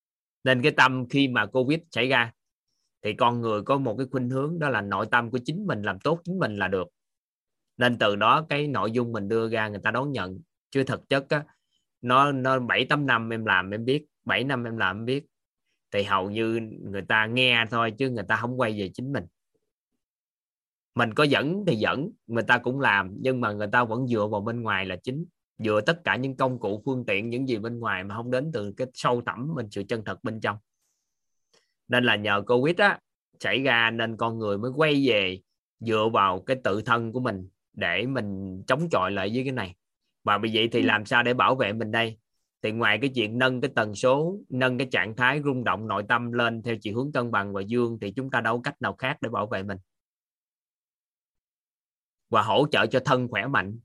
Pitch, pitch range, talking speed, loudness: 120 Hz, 105-130 Hz, 225 wpm, -25 LUFS